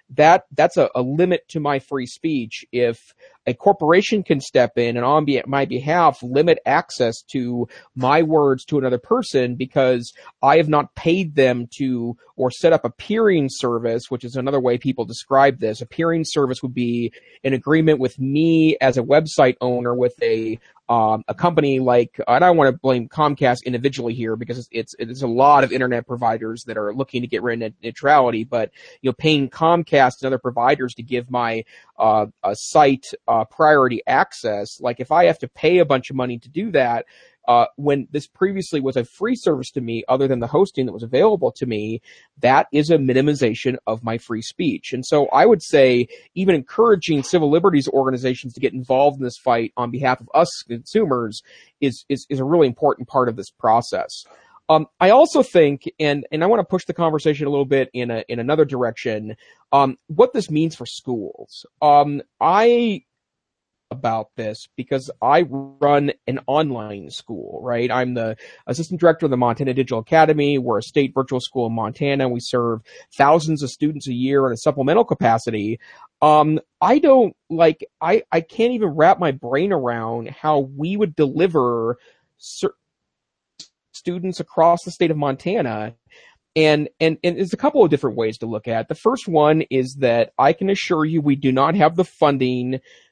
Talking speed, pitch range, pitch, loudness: 190 wpm, 120-155 Hz, 135 Hz, -19 LUFS